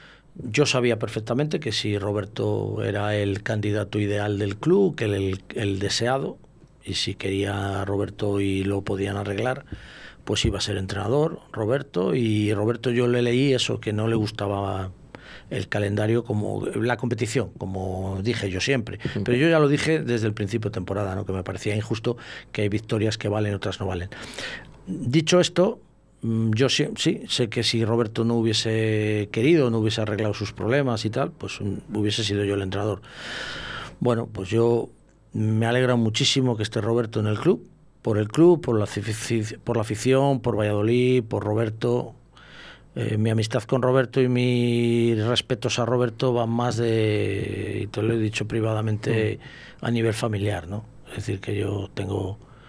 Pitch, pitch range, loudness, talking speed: 110 Hz, 105-120 Hz, -24 LUFS, 175 wpm